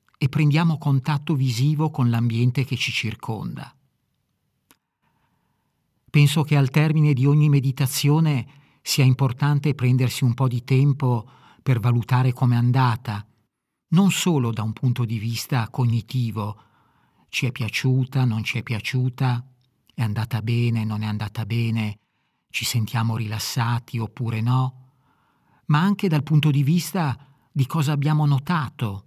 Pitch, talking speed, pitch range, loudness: 130 Hz, 135 wpm, 115-145 Hz, -22 LUFS